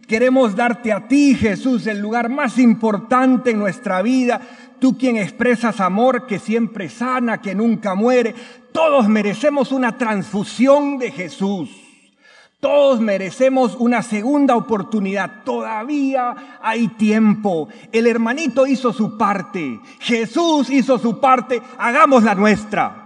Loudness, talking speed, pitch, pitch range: -17 LUFS, 125 wpm, 240 Hz, 215-255 Hz